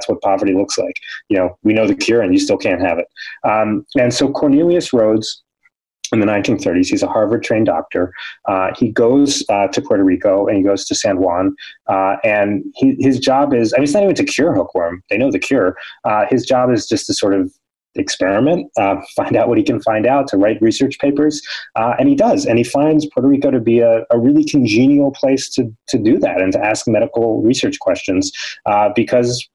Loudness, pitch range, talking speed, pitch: -15 LUFS, 115-155 Hz, 215 wpm, 135 Hz